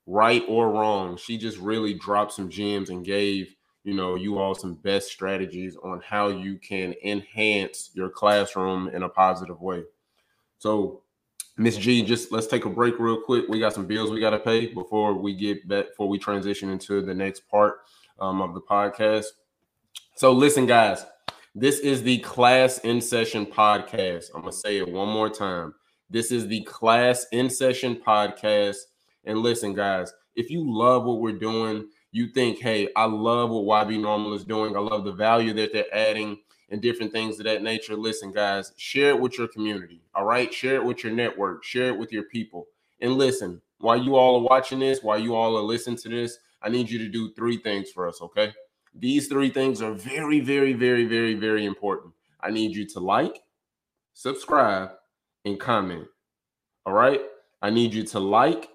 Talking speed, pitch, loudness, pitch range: 190 wpm, 110 Hz, -24 LUFS, 100-120 Hz